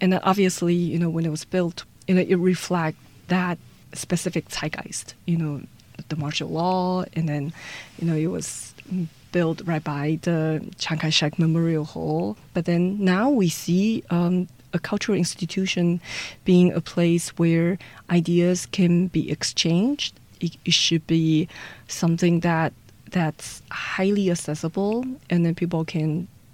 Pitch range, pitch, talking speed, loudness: 155-180 Hz, 170 Hz, 145 wpm, -23 LUFS